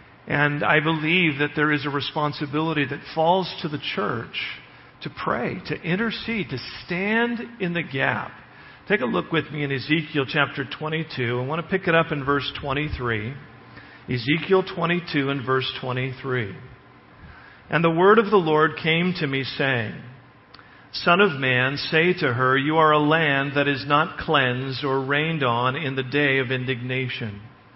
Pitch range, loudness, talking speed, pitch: 130-160 Hz, -22 LUFS, 165 wpm, 145 Hz